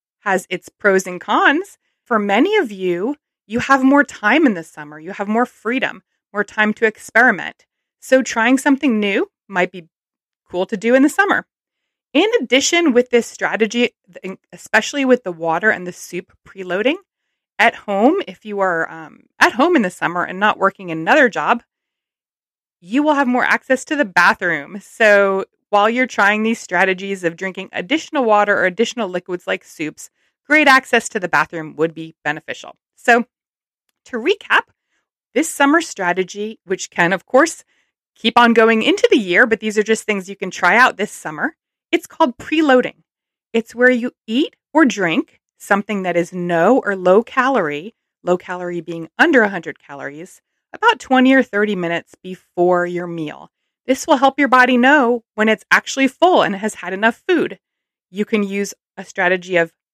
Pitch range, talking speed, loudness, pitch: 185-265 Hz, 175 wpm, -16 LUFS, 220 Hz